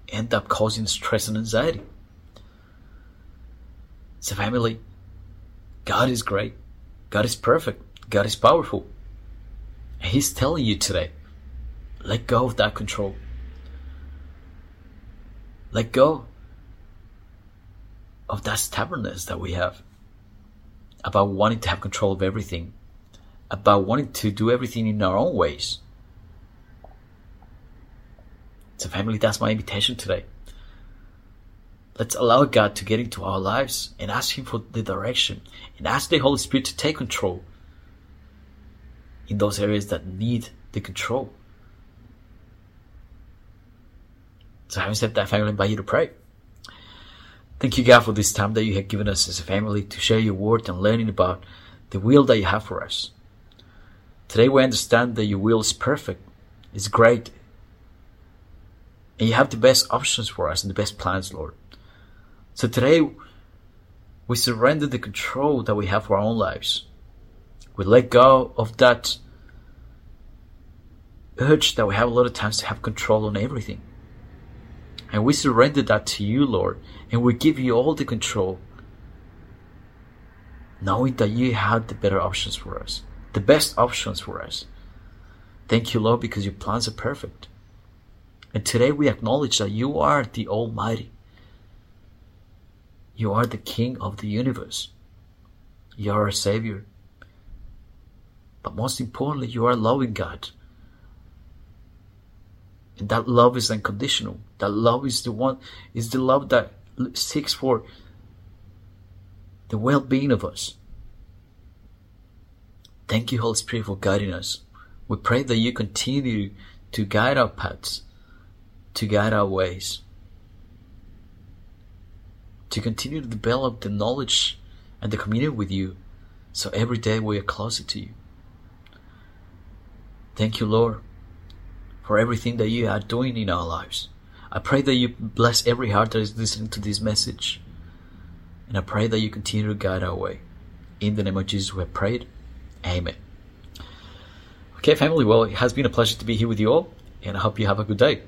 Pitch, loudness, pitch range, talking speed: 100 Hz, -22 LUFS, 95-115 Hz, 150 wpm